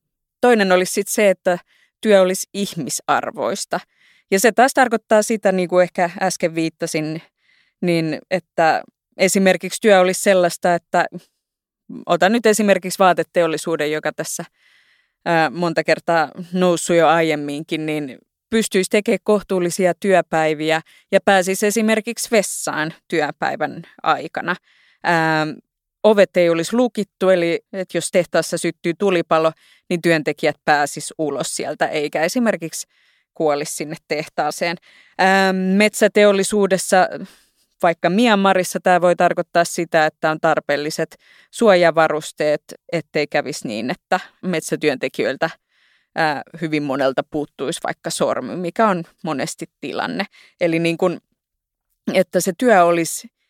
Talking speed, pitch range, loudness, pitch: 115 wpm, 160-195 Hz, -18 LUFS, 175 Hz